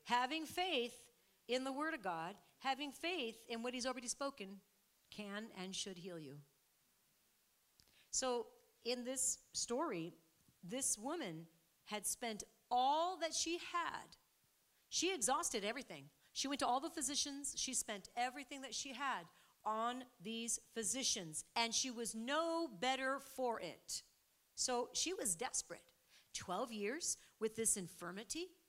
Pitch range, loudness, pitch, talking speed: 210-280 Hz, -41 LUFS, 245 Hz, 135 wpm